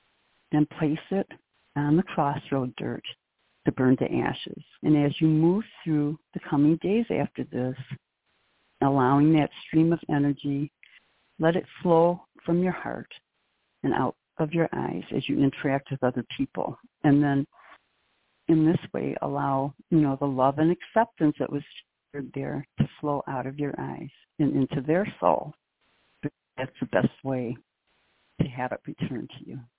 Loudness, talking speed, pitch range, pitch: -26 LUFS, 155 wpm, 135-165 Hz, 145 Hz